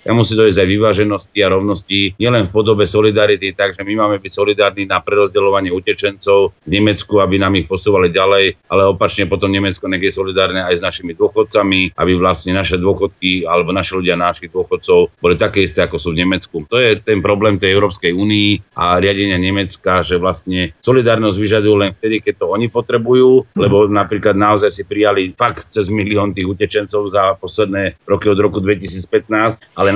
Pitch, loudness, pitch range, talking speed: 100 Hz, -14 LUFS, 95-105 Hz, 180 wpm